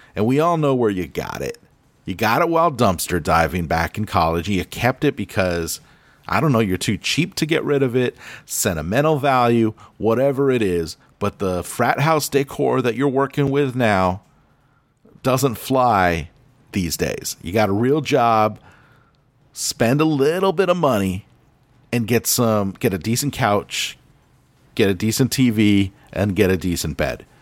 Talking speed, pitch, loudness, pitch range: 170 wpm, 120 Hz, -19 LUFS, 100-140 Hz